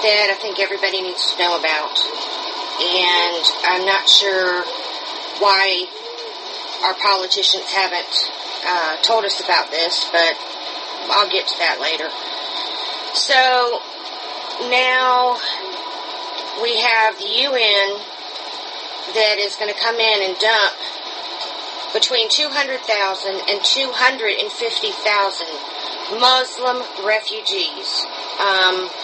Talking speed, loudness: 100 wpm, -17 LUFS